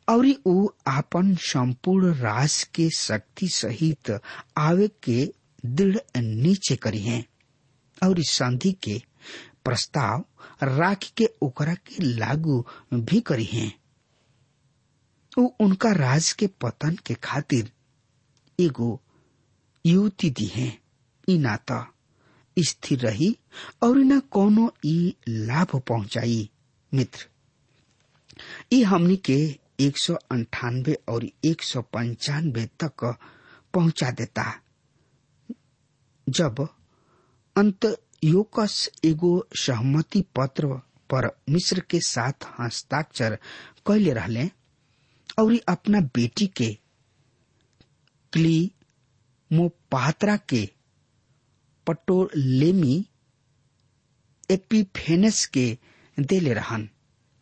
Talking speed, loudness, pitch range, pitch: 85 wpm, -24 LUFS, 125-175 Hz, 140 Hz